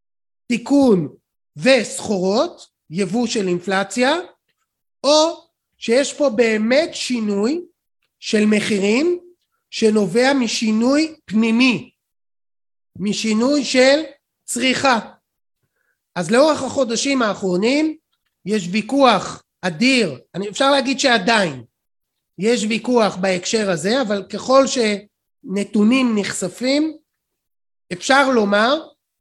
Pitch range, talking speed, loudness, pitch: 205-275 Hz, 80 wpm, -18 LUFS, 235 Hz